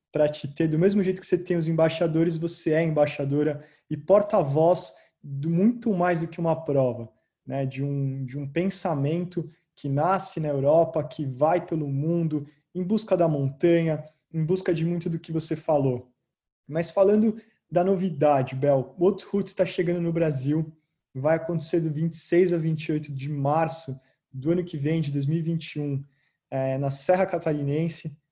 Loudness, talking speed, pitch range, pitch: -25 LUFS, 165 wpm, 145-175 Hz, 160 Hz